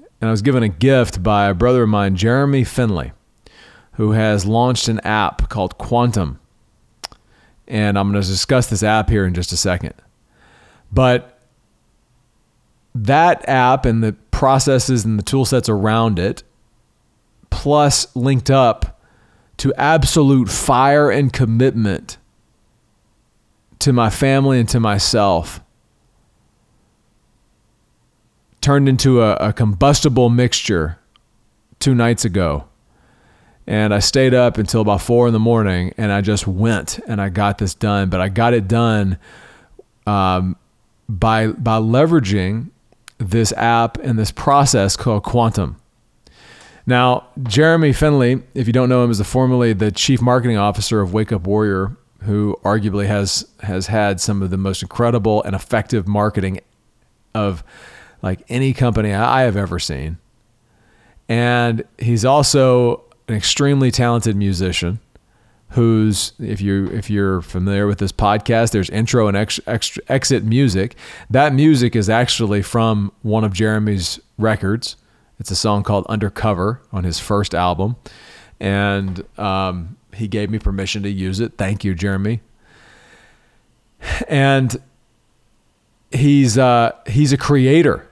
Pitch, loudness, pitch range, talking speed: 110 Hz, -16 LUFS, 100-125 Hz, 135 wpm